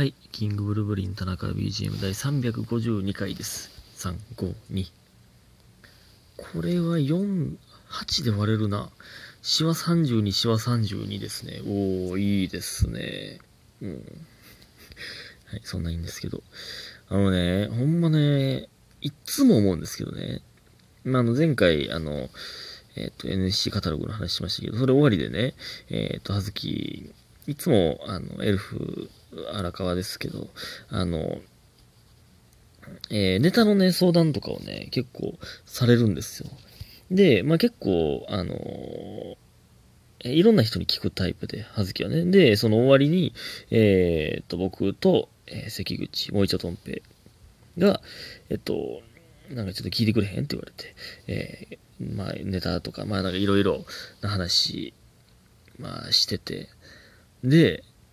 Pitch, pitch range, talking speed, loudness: 105 Hz, 95-135 Hz, 255 characters per minute, -25 LUFS